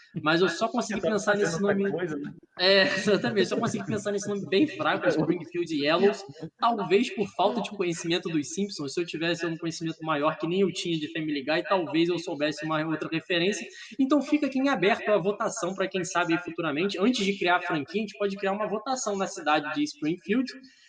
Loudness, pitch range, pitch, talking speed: -27 LUFS, 165-210 Hz, 190 Hz, 200 wpm